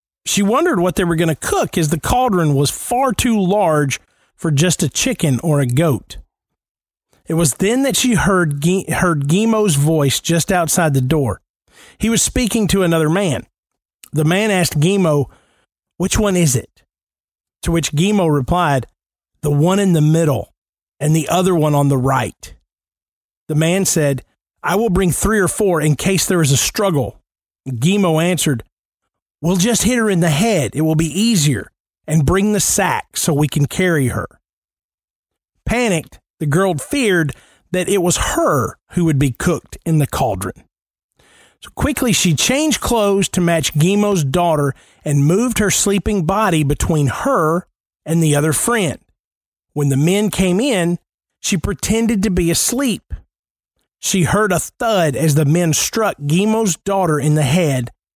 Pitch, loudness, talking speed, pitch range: 165 Hz, -16 LUFS, 165 wpm, 145-195 Hz